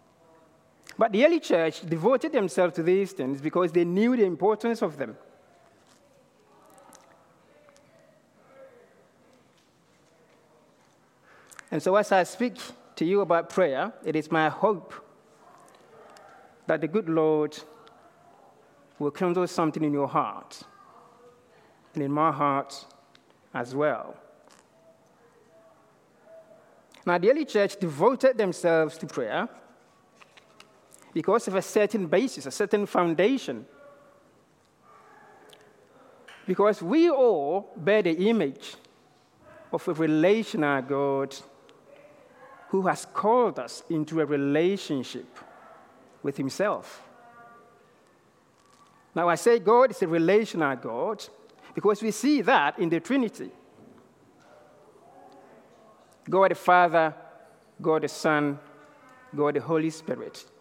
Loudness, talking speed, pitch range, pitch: -25 LUFS, 105 wpm, 155-225 Hz, 180 Hz